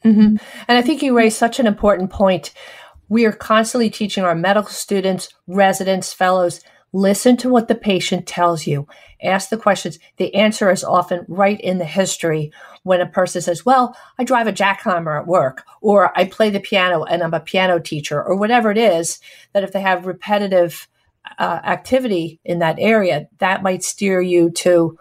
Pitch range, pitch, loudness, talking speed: 180-215 Hz, 190 Hz, -17 LUFS, 185 wpm